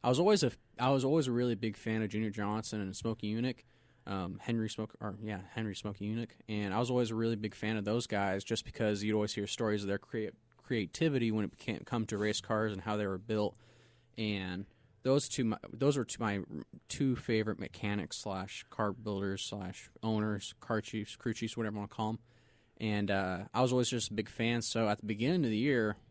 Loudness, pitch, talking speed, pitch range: -35 LUFS, 110 Hz, 225 wpm, 105-115 Hz